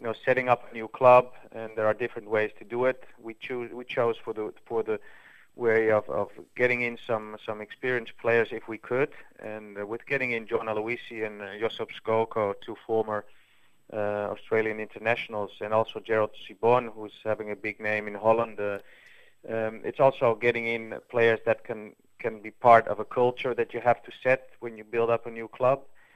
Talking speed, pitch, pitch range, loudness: 200 wpm, 115 Hz, 110-120 Hz, -27 LUFS